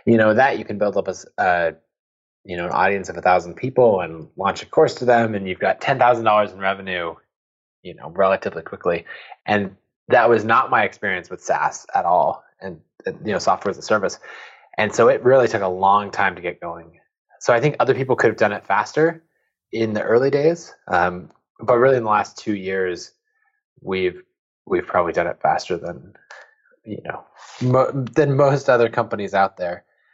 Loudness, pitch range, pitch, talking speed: -19 LUFS, 95-160 Hz, 115 Hz, 205 wpm